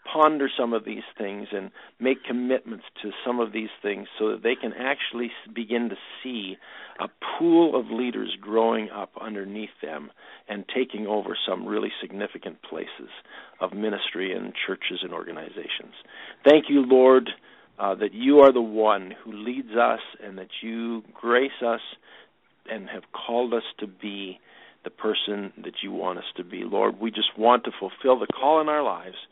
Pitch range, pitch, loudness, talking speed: 105-130 Hz, 115 Hz, -25 LUFS, 170 wpm